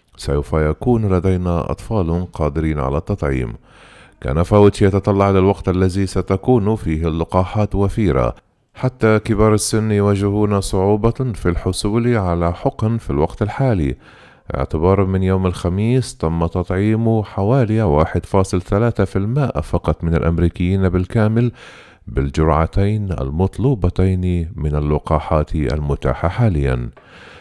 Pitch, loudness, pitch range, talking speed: 95 Hz, -18 LUFS, 80-105 Hz, 100 wpm